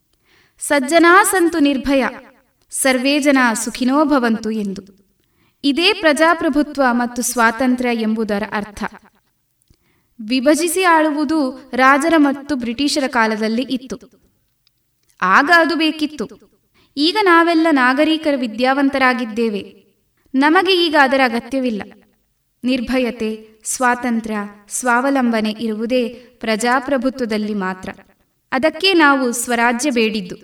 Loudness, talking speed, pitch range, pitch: -16 LUFS, 80 wpm, 225-295 Hz, 255 Hz